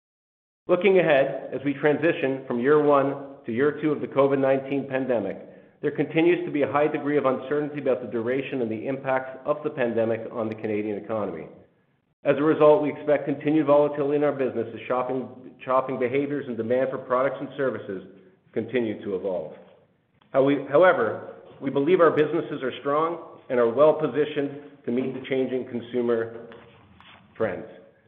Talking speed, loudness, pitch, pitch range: 170 wpm, -24 LUFS, 135 Hz, 125-145 Hz